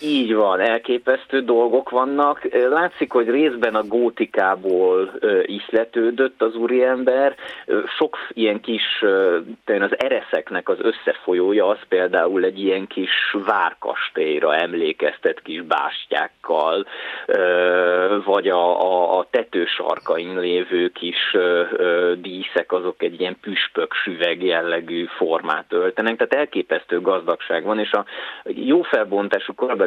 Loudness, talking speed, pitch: -20 LUFS, 110 wpm, 125 Hz